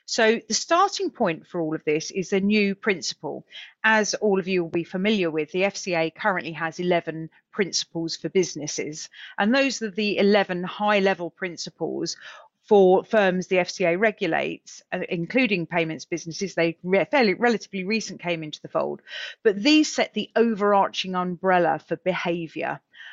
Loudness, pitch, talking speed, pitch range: -23 LUFS, 190 Hz, 155 wpm, 170-215 Hz